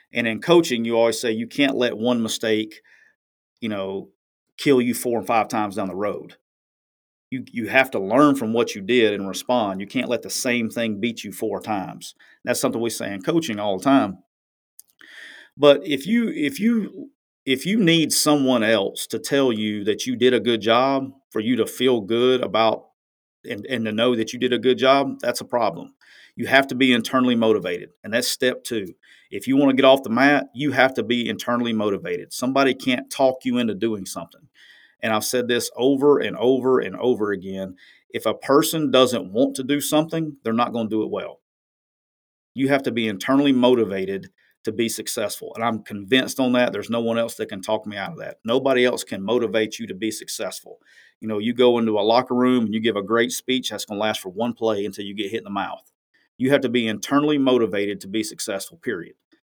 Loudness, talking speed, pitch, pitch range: -21 LUFS, 220 wpm, 120 Hz, 110-135 Hz